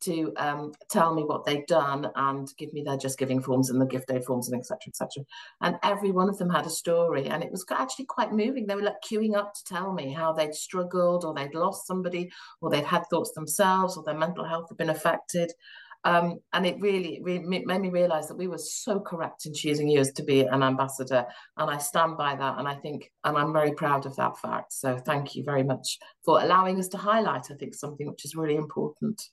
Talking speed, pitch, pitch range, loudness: 240 wpm, 160 Hz, 140-180 Hz, -28 LUFS